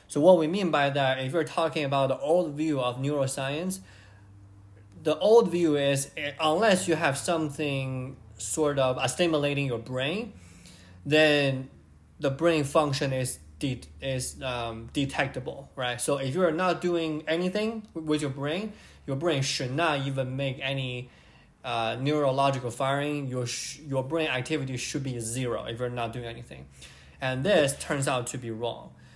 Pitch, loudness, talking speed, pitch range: 135 Hz, -27 LUFS, 160 wpm, 125-155 Hz